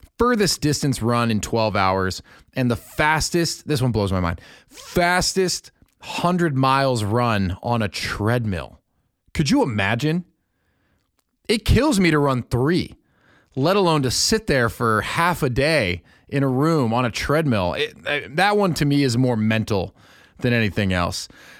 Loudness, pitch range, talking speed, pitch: -20 LUFS, 110-155 Hz, 155 wpm, 125 Hz